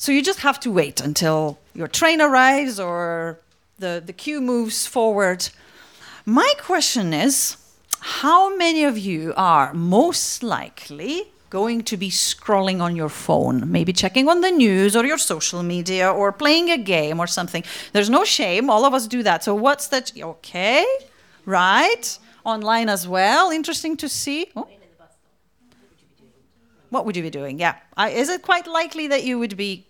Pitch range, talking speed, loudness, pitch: 180-290 Hz, 165 wpm, -19 LUFS, 225 Hz